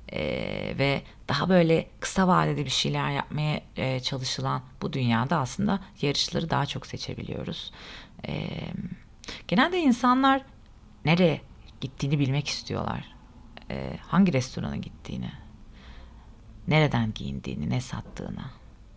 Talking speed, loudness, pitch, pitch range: 105 wpm, -27 LUFS, 140 Hz, 110-175 Hz